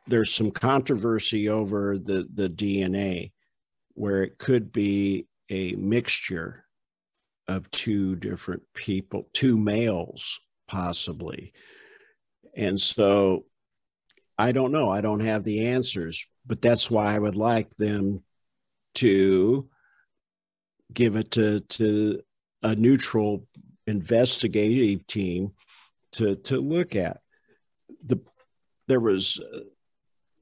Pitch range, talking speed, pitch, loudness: 95-115 Hz, 105 wpm, 105 Hz, -25 LUFS